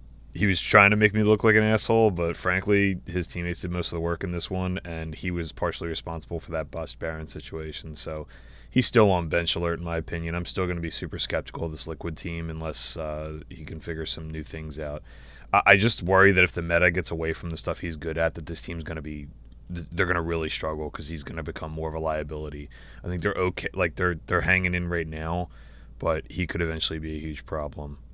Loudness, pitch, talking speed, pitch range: -26 LUFS, 85 Hz, 245 wpm, 80-90 Hz